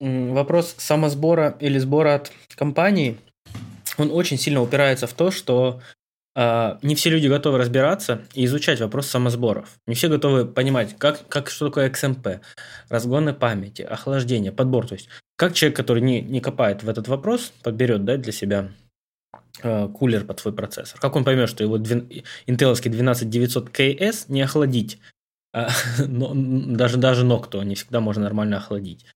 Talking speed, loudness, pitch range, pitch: 155 wpm, -21 LUFS, 115-140 Hz, 125 Hz